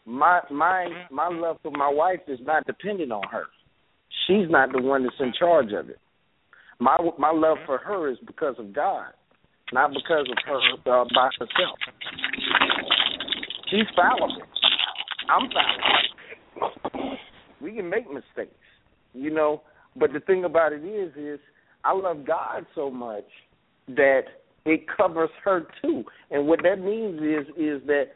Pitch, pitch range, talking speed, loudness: 155 Hz, 145-180 Hz, 155 wpm, -24 LUFS